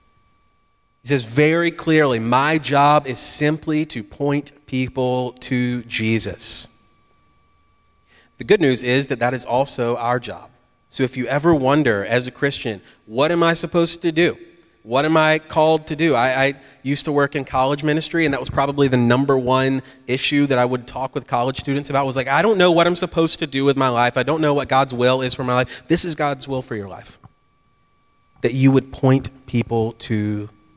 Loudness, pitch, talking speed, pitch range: -19 LUFS, 135 Hz, 200 wpm, 120-145 Hz